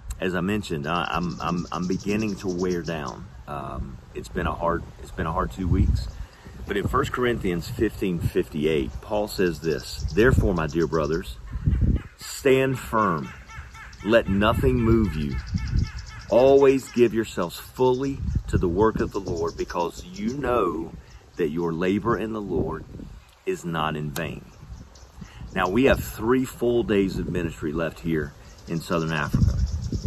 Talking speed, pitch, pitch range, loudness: 150 wpm, 90 Hz, 80-110 Hz, -25 LUFS